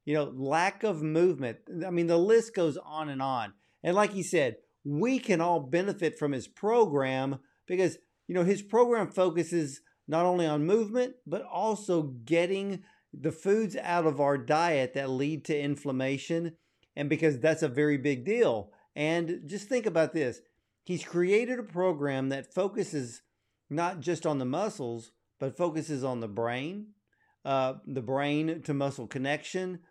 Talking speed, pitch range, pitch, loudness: 165 wpm, 140-185 Hz, 160 Hz, -30 LUFS